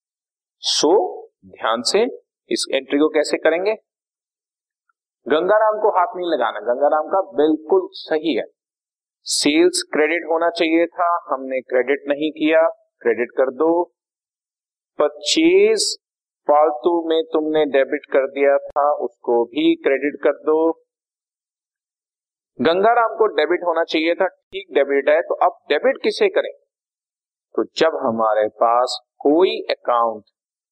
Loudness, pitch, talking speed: -19 LUFS, 170 Hz, 125 wpm